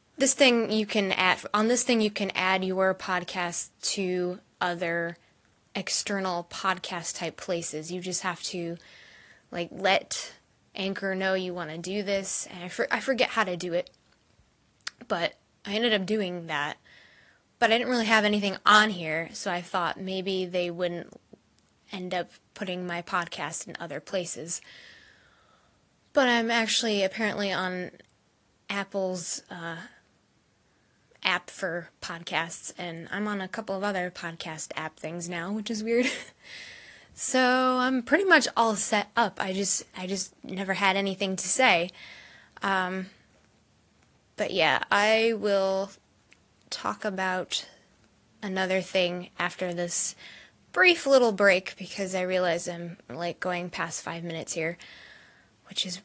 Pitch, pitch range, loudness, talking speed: 190 Hz, 175-210 Hz, -26 LUFS, 145 wpm